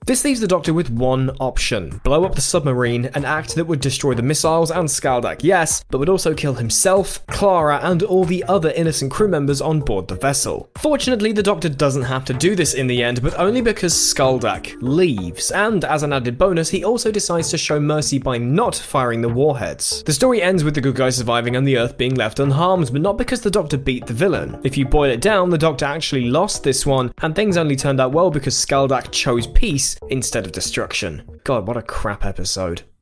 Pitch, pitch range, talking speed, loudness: 145 Hz, 130-175 Hz, 220 wpm, -18 LUFS